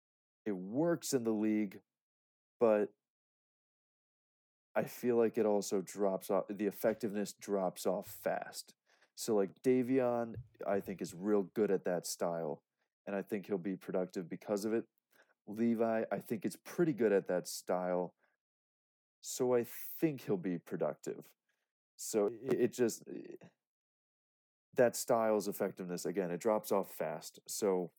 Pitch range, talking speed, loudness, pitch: 95-115 Hz, 140 wpm, -36 LUFS, 105 Hz